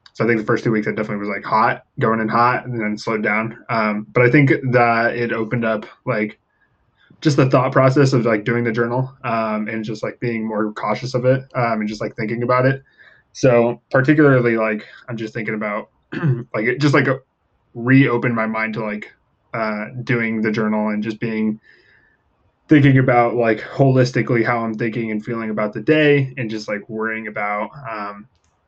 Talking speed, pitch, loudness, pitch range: 195 wpm, 115 Hz, -18 LUFS, 110-125 Hz